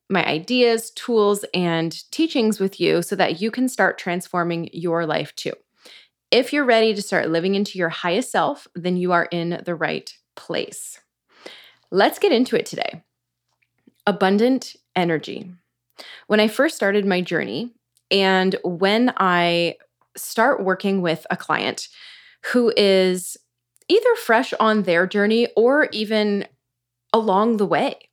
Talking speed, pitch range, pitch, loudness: 140 wpm, 170-225 Hz, 195 Hz, -20 LUFS